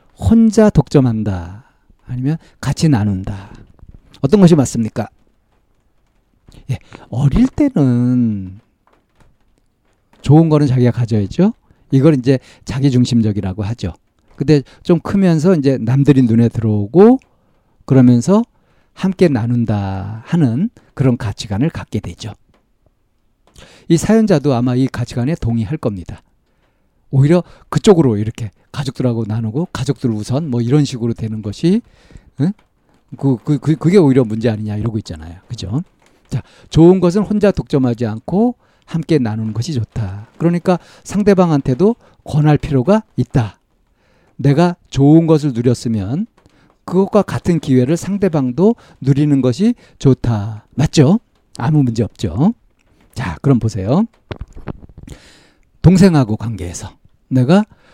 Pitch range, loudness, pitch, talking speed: 110-165 Hz, -15 LUFS, 130 Hz, 265 characters per minute